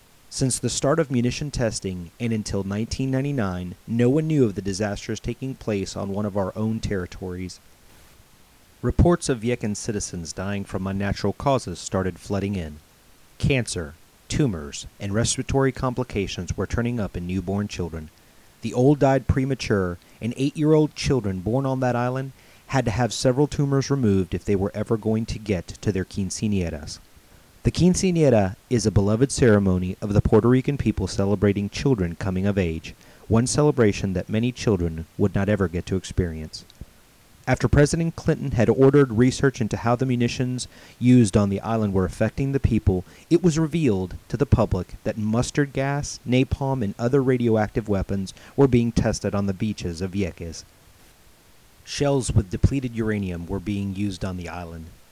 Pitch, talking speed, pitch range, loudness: 110 Hz, 160 wpm, 95-125 Hz, -23 LUFS